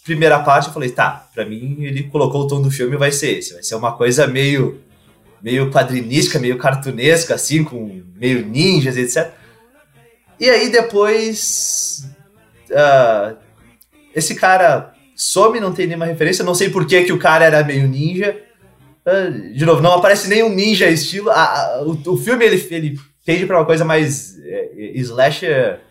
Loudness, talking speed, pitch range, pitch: -15 LUFS, 170 wpm, 135-190 Hz, 160 Hz